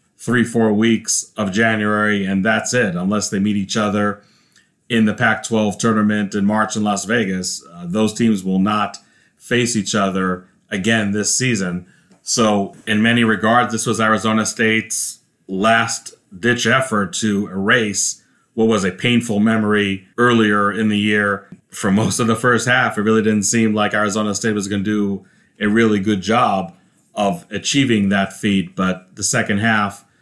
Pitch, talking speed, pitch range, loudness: 105 Hz, 170 wpm, 100-115 Hz, -17 LUFS